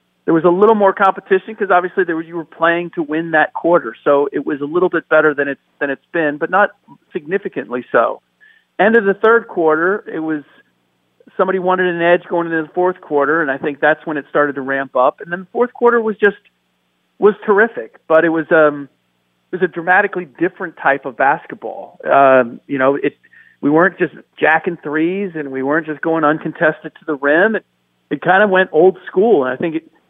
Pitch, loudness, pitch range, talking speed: 165 Hz, -15 LUFS, 145-185 Hz, 215 wpm